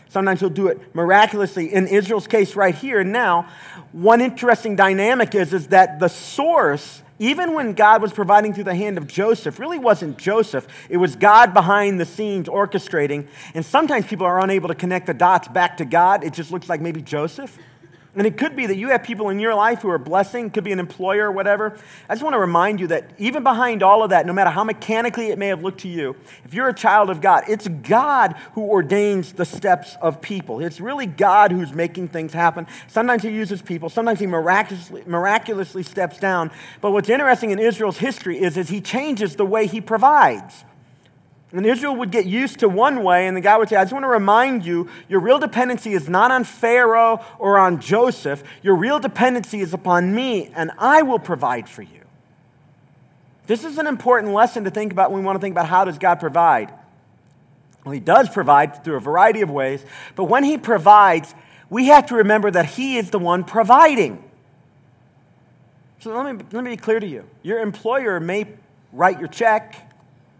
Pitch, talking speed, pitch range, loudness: 195 Hz, 205 wpm, 175-225 Hz, -18 LUFS